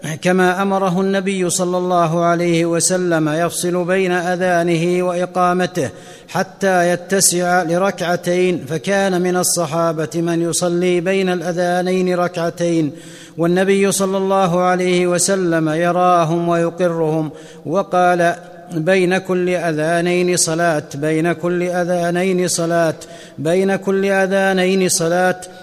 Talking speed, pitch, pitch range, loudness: 110 wpm, 180 Hz, 170-185 Hz, -16 LUFS